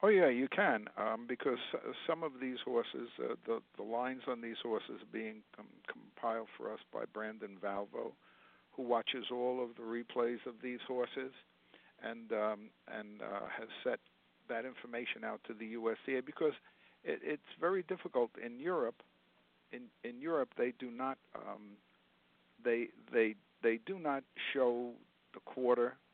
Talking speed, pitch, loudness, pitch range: 165 wpm, 120 Hz, -39 LUFS, 110-130 Hz